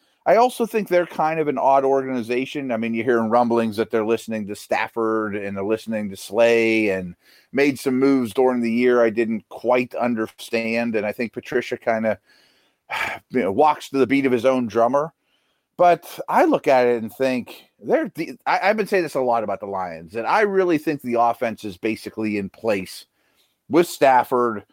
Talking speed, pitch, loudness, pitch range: 200 wpm, 120 Hz, -21 LUFS, 110-135 Hz